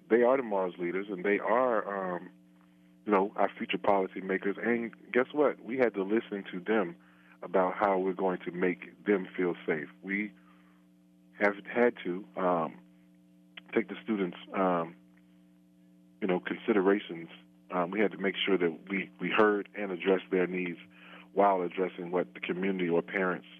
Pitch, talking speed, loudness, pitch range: 90 Hz, 165 wpm, -31 LUFS, 60-100 Hz